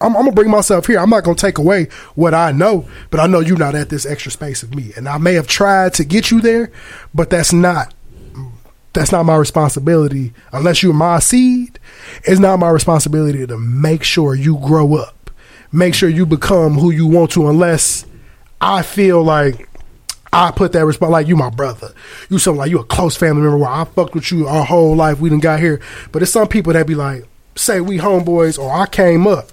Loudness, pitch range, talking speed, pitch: -13 LUFS, 150-180 Hz, 220 wpm, 165 Hz